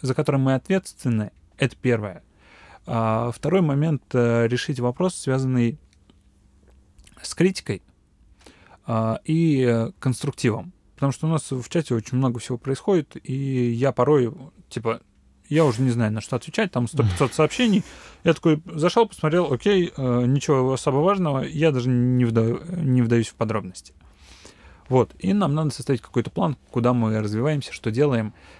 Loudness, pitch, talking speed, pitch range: -23 LUFS, 125 Hz, 145 wpm, 110-150 Hz